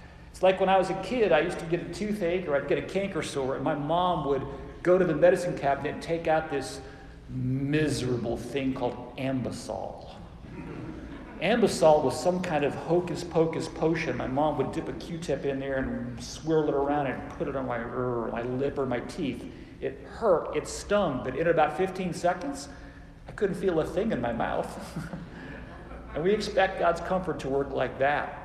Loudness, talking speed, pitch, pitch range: -28 LUFS, 200 wpm, 155 Hz, 135-175 Hz